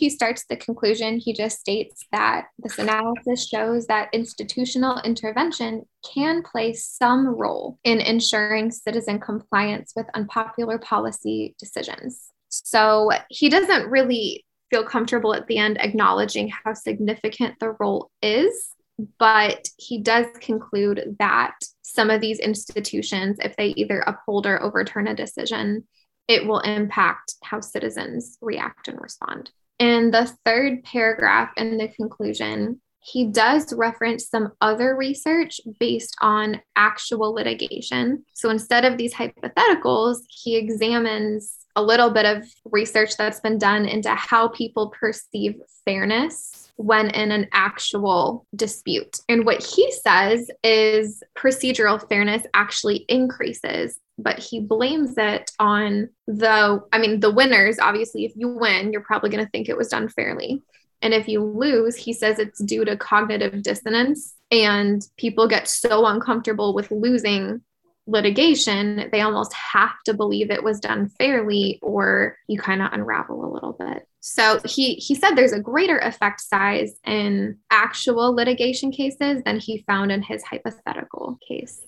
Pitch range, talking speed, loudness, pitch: 210-240 Hz, 145 wpm, -21 LUFS, 220 Hz